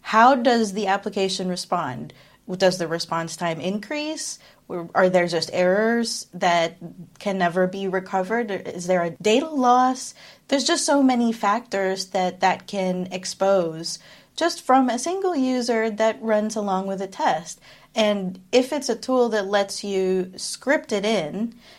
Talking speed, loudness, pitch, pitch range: 150 wpm, -22 LUFS, 195 Hz, 185-235 Hz